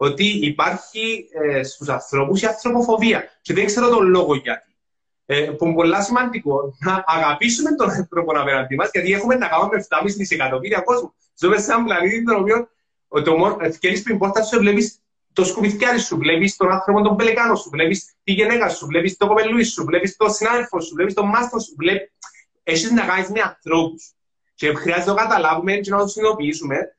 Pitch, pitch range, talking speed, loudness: 195 Hz, 160-220 Hz, 185 wpm, -18 LUFS